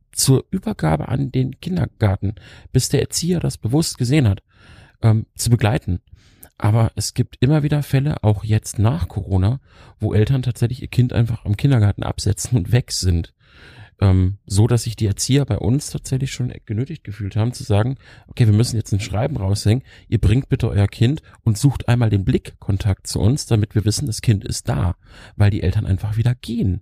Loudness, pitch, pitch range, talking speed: -20 LUFS, 110 Hz, 100-125 Hz, 190 wpm